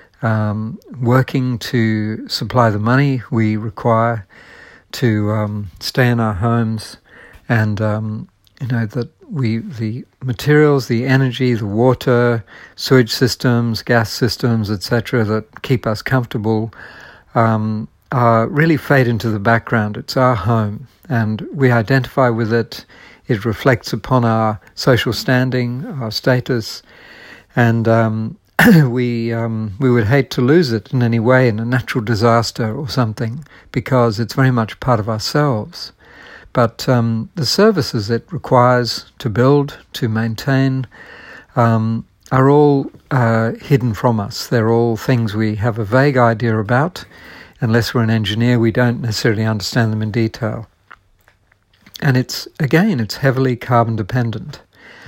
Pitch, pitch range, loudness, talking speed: 120 Hz, 110-130 Hz, -16 LUFS, 145 wpm